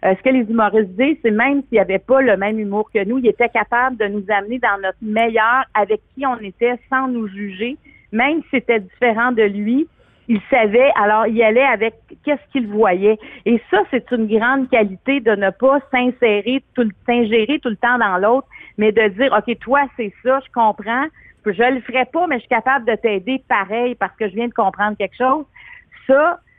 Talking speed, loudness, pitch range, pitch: 210 wpm, -17 LUFS, 215-260 Hz, 235 Hz